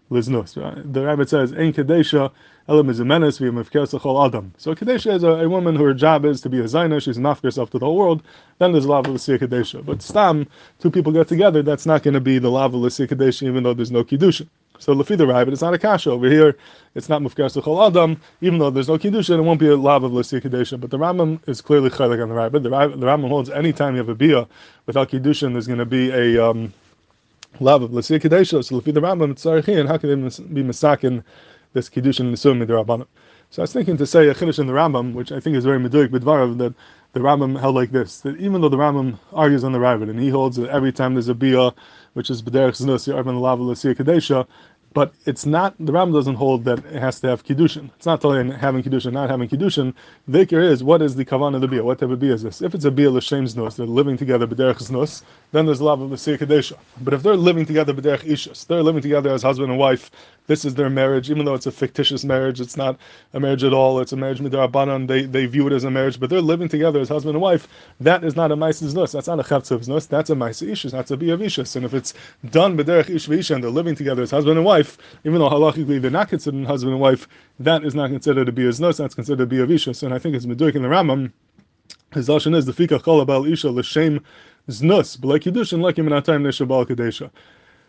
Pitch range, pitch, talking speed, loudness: 130-155 Hz, 140 Hz, 240 wpm, -18 LUFS